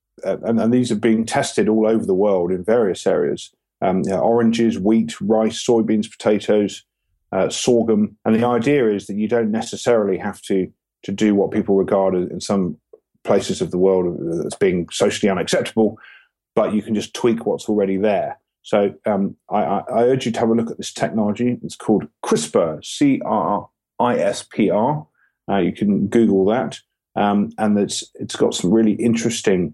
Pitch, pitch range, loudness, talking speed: 110 Hz, 100-115 Hz, -19 LUFS, 185 wpm